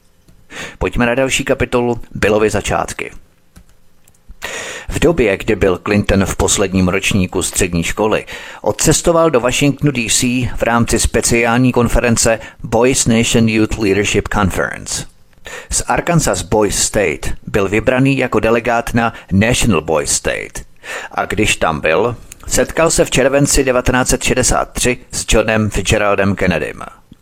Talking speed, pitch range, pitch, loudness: 120 wpm, 105-125 Hz, 115 Hz, -14 LUFS